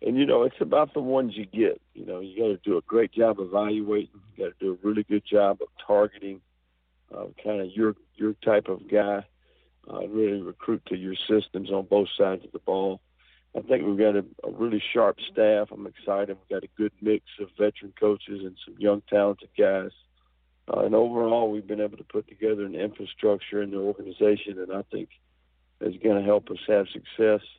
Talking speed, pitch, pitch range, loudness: 215 wpm, 105 Hz, 95-105 Hz, -26 LUFS